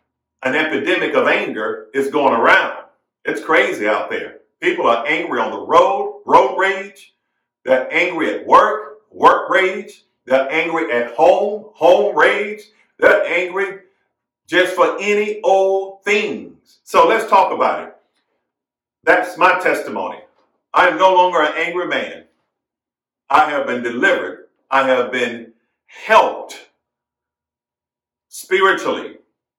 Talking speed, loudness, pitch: 125 wpm, -16 LUFS, 195 Hz